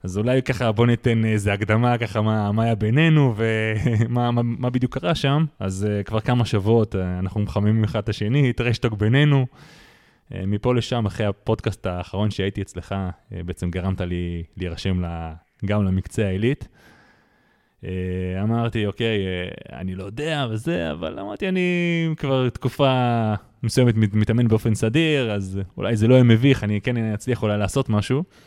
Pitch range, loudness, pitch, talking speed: 100-125 Hz, -22 LUFS, 110 Hz, 150 wpm